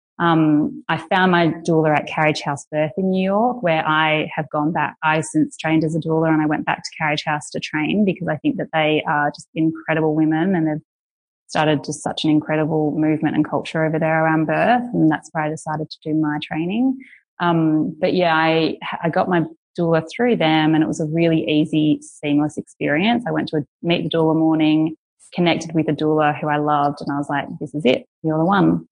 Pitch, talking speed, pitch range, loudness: 155 Hz, 220 wpm, 150-160 Hz, -19 LUFS